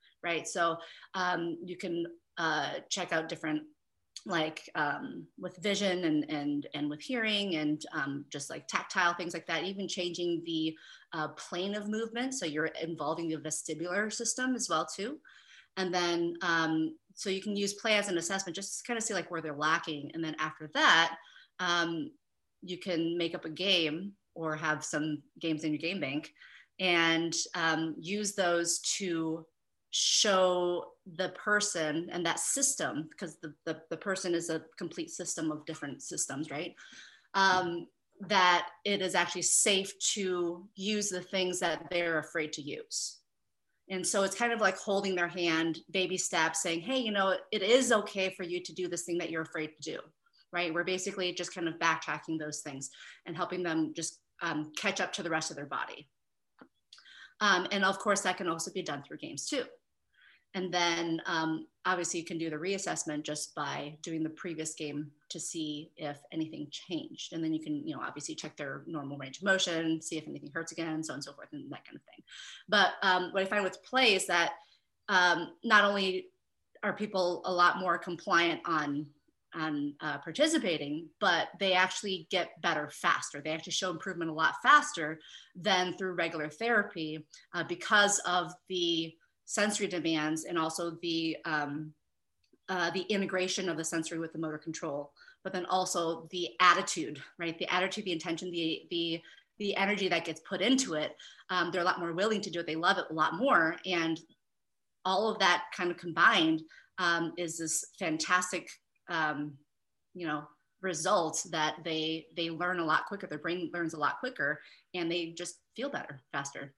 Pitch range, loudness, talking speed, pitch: 160-190 Hz, -32 LUFS, 185 wpm, 170 Hz